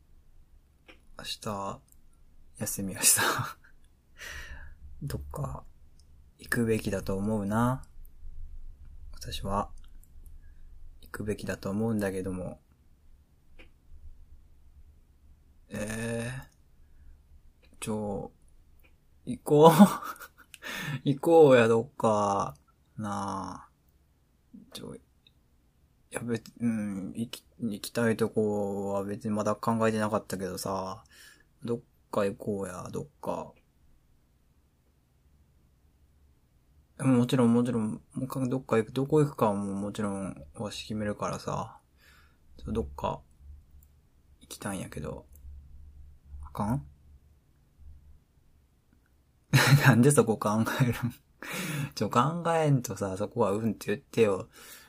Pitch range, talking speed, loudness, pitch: 70-110 Hz, 180 characters per minute, -29 LUFS, 75 Hz